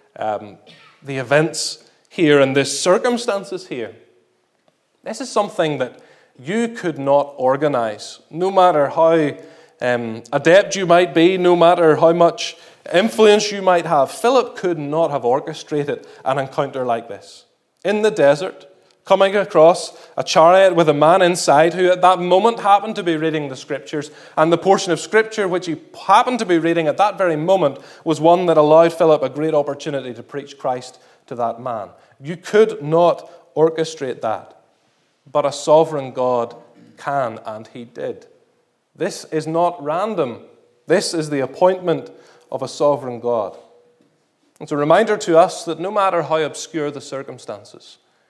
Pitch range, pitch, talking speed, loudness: 145-185 Hz, 165 Hz, 160 wpm, -17 LUFS